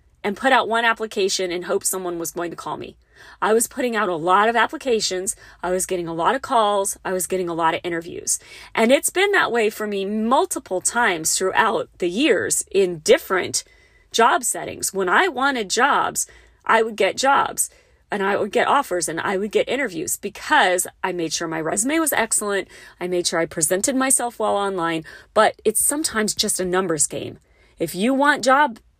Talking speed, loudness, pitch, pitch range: 200 wpm, -20 LUFS, 210 Hz, 180-265 Hz